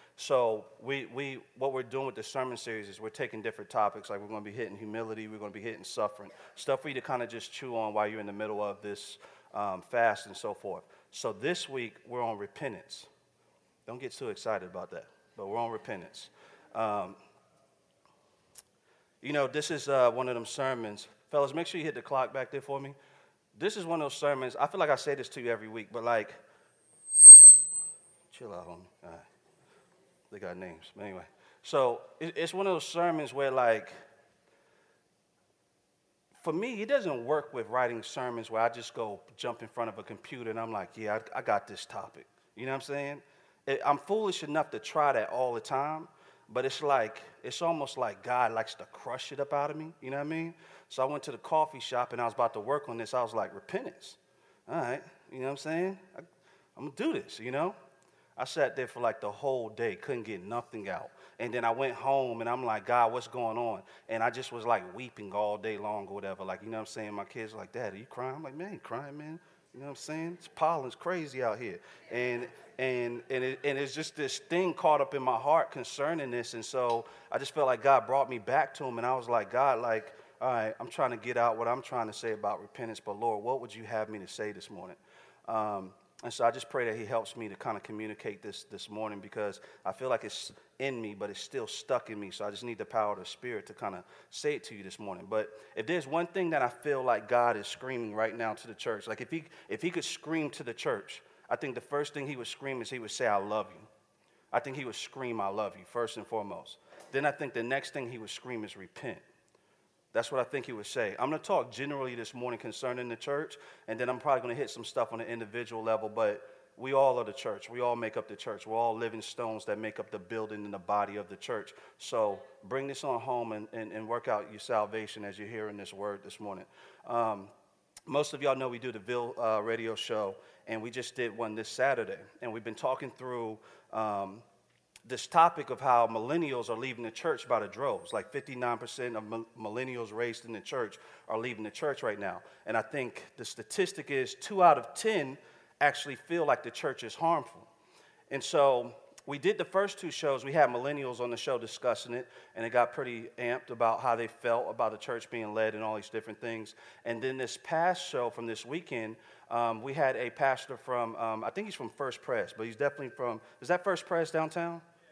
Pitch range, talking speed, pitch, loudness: 110-140 Hz, 240 wpm, 120 Hz, -29 LUFS